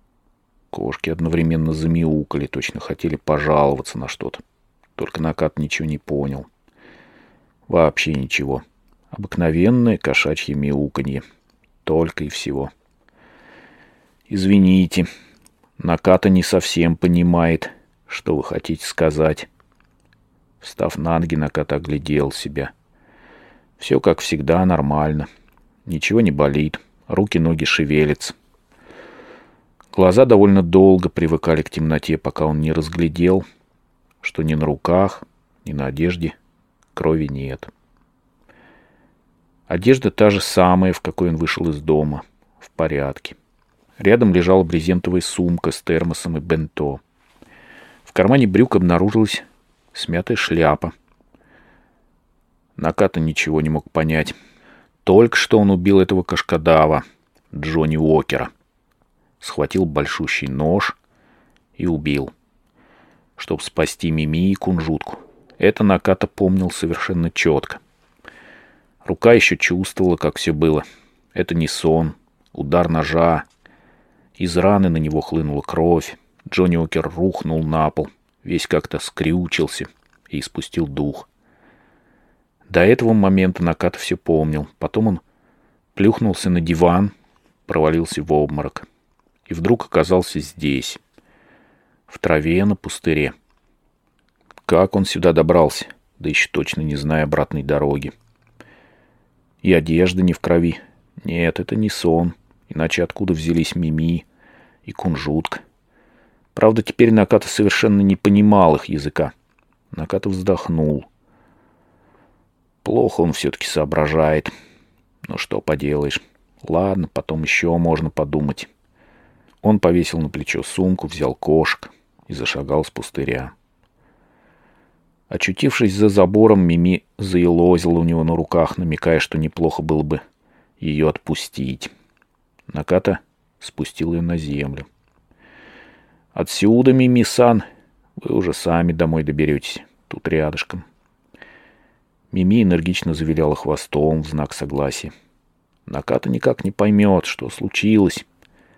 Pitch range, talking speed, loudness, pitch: 75-90 Hz, 110 wpm, -18 LUFS, 80 Hz